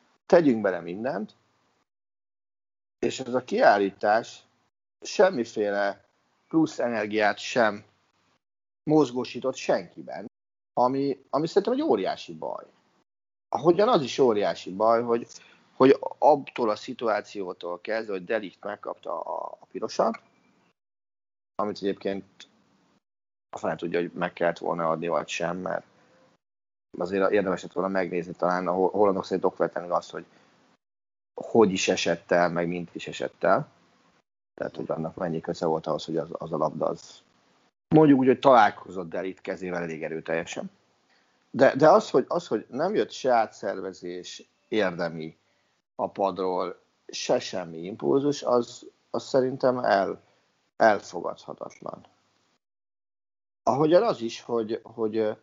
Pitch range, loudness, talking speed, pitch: 90-115 Hz, -26 LUFS, 125 wpm, 100 Hz